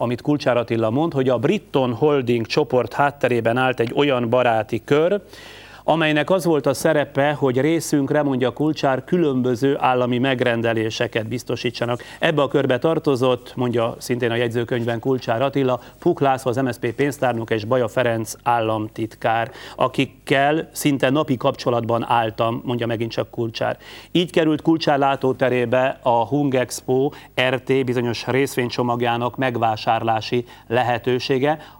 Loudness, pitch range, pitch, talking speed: -20 LUFS, 120-140 Hz, 130 Hz, 130 wpm